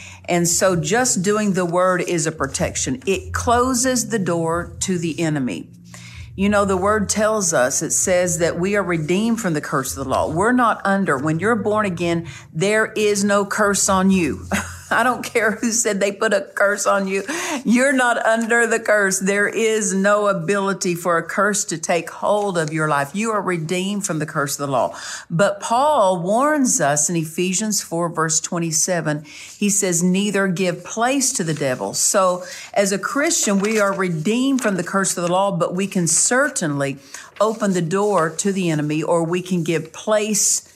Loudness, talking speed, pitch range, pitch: -19 LUFS, 190 wpm, 170-210 Hz, 195 Hz